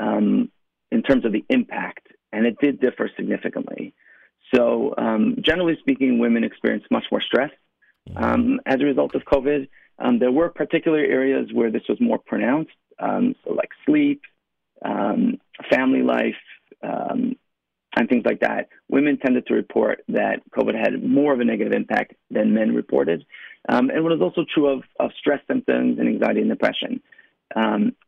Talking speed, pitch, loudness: 165 wpm, 165 Hz, -21 LUFS